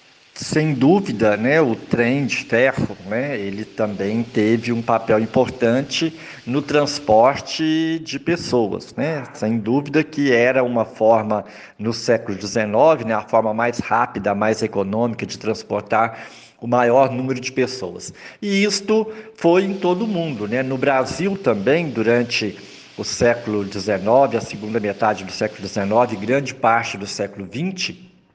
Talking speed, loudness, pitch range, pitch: 145 wpm, -19 LUFS, 110-145 Hz, 120 Hz